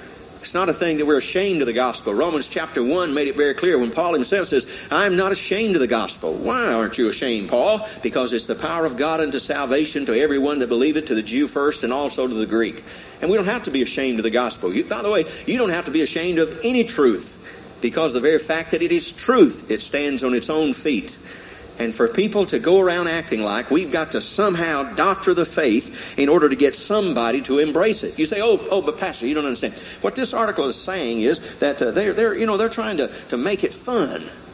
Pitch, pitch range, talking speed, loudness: 155 Hz, 135-195 Hz, 250 wpm, -20 LUFS